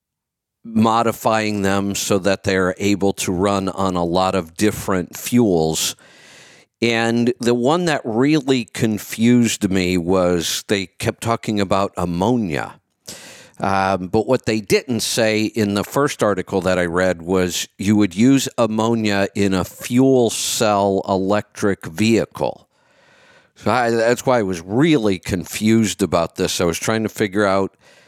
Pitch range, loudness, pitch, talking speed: 95-115 Hz, -18 LUFS, 105 Hz, 145 wpm